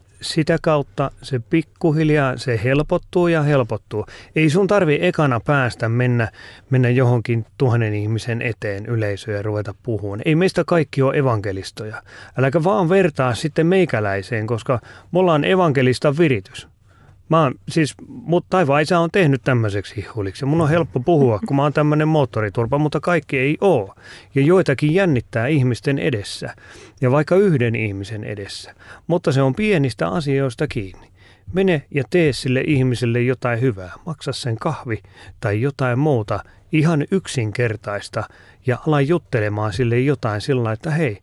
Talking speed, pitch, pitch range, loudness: 145 wpm, 130 Hz, 110-155 Hz, -19 LUFS